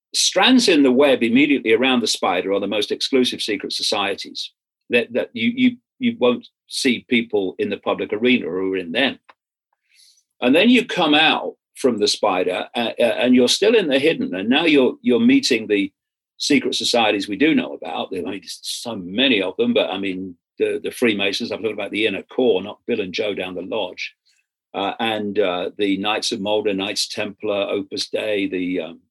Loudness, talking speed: -19 LUFS, 200 wpm